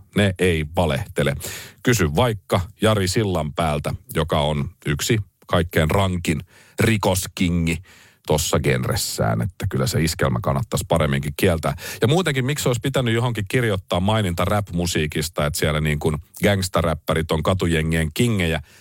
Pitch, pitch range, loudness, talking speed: 90 Hz, 80-105 Hz, -21 LUFS, 130 wpm